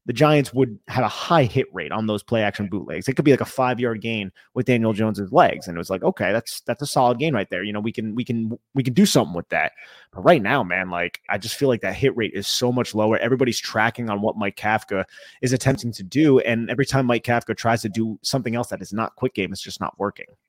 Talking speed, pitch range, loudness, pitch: 275 wpm, 105-130 Hz, -22 LUFS, 115 Hz